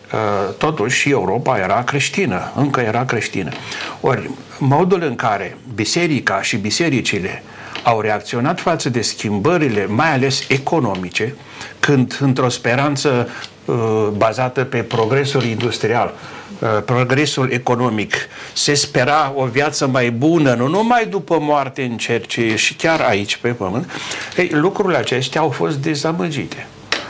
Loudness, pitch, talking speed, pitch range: -17 LUFS, 130 Hz, 120 wpm, 115-145 Hz